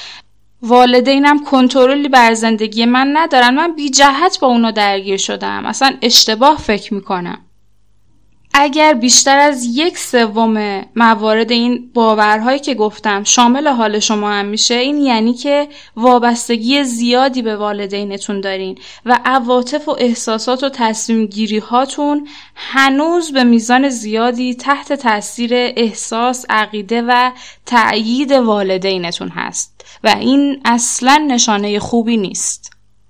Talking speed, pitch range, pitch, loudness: 120 wpm, 215-270 Hz, 240 Hz, -12 LUFS